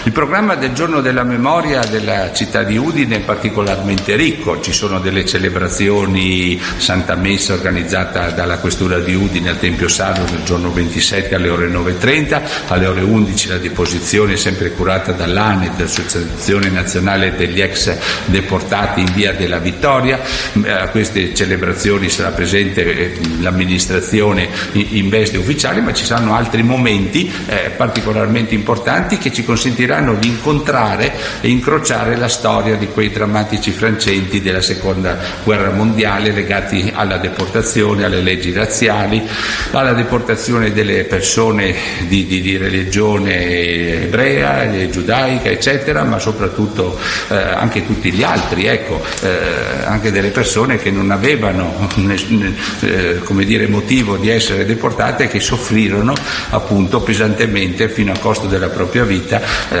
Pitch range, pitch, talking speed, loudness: 90-110 Hz, 100 Hz, 135 wpm, -14 LUFS